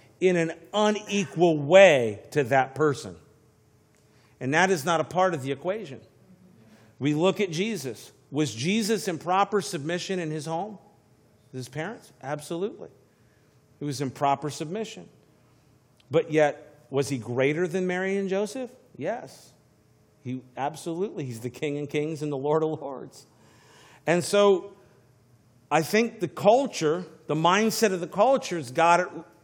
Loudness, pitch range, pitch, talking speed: -25 LUFS, 135-185 Hz, 155 Hz, 145 wpm